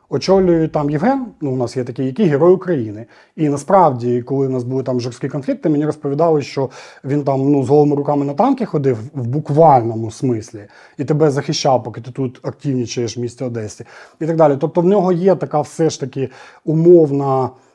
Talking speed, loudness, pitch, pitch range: 195 wpm, -16 LUFS, 140 Hz, 130-160 Hz